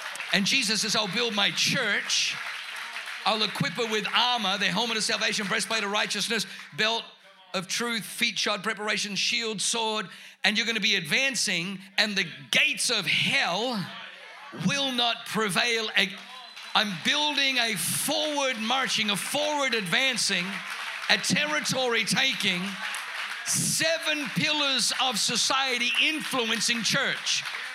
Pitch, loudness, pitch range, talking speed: 220 Hz, -25 LUFS, 195-245 Hz, 125 wpm